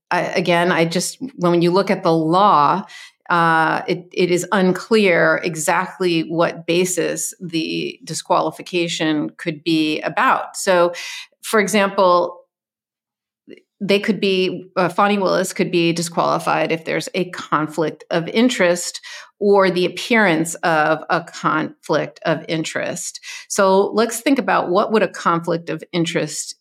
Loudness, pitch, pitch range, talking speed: -18 LUFS, 180 Hz, 165-200 Hz, 135 wpm